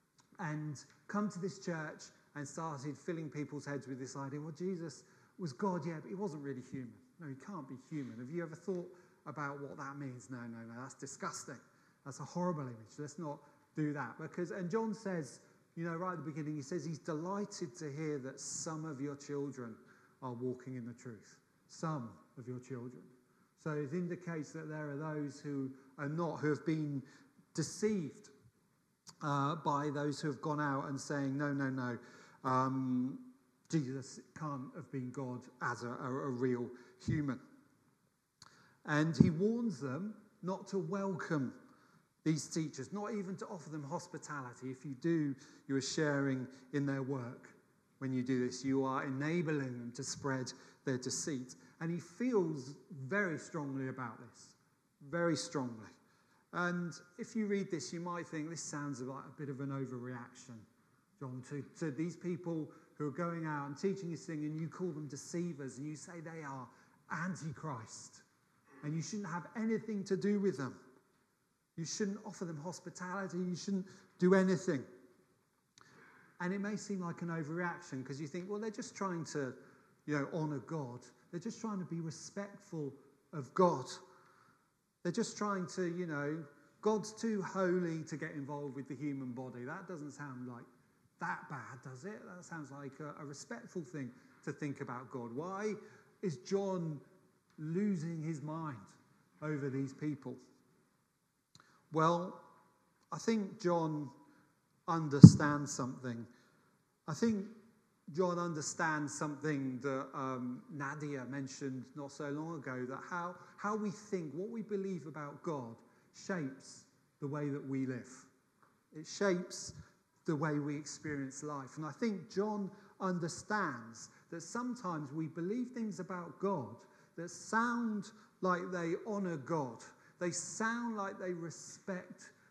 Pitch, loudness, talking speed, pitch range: 155 Hz, -39 LUFS, 160 wpm, 135-180 Hz